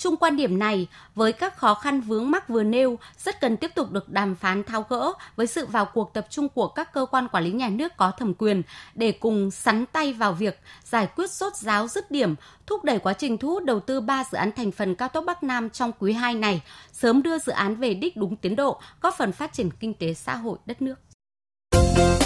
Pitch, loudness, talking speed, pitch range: 225 Hz, -25 LUFS, 245 wpm, 200-275 Hz